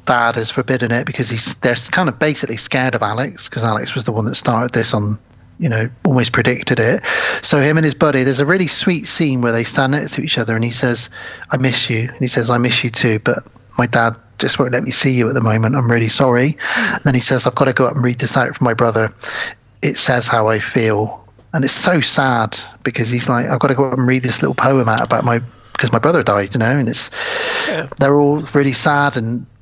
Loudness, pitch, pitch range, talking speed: -15 LUFS, 125 Hz, 115-135 Hz, 255 wpm